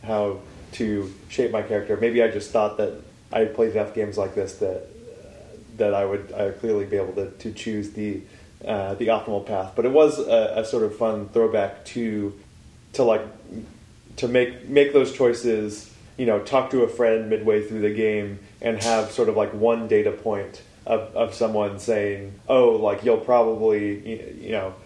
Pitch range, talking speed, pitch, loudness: 100-115 Hz, 190 wpm, 110 Hz, -23 LUFS